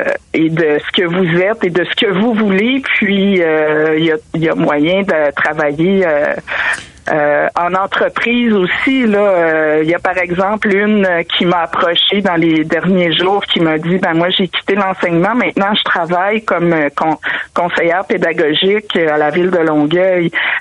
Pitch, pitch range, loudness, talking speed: 180 Hz, 160-195 Hz, -13 LUFS, 185 wpm